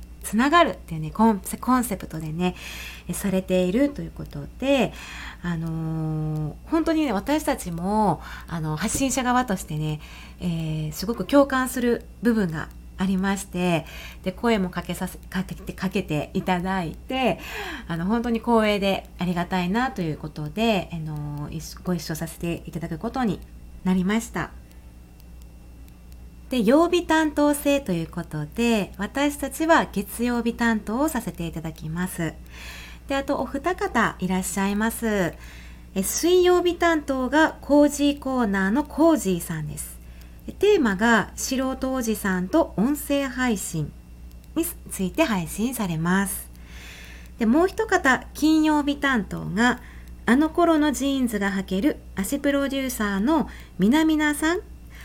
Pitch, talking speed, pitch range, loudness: 200 Hz, 280 characters per minute, 165-270 Hz, -24 LUFS